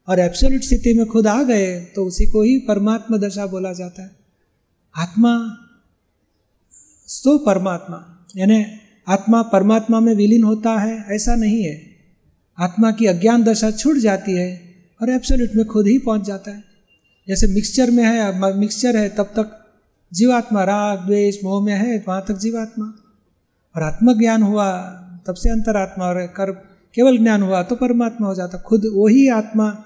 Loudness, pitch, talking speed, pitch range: -17 LUFS, 210 Hz, 160 wpm, 190-225 Hz